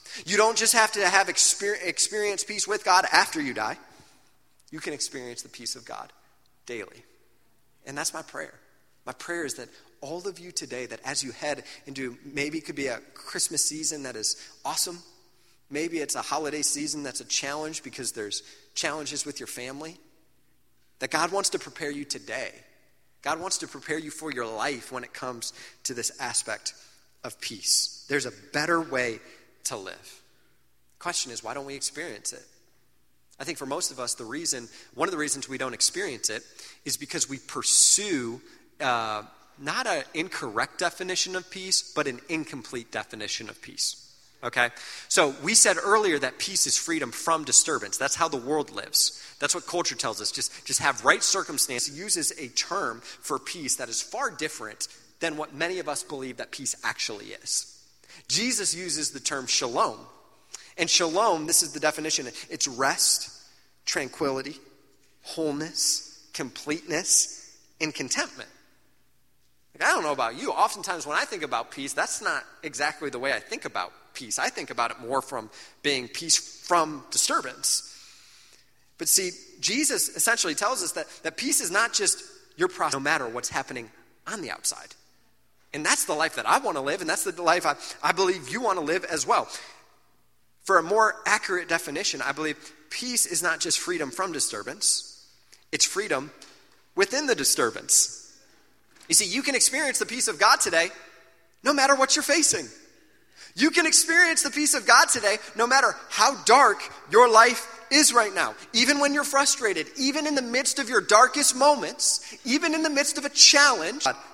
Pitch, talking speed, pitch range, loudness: 165 Hz, 180 wpm, 140-230 Hz, -24 LUFS